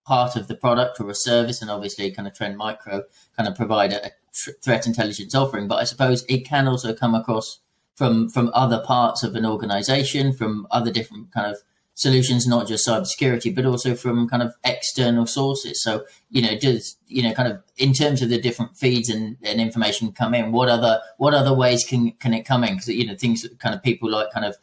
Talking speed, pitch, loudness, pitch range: 225 wpm, 120 Hz, -21 LUFS, 110-125 Hz